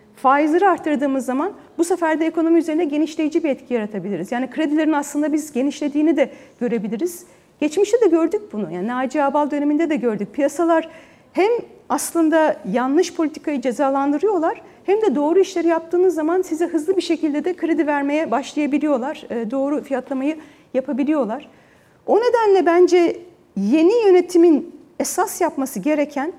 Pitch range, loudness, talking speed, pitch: 275-340 Hz, -19 LUFS, 135 wpm, 310 Hz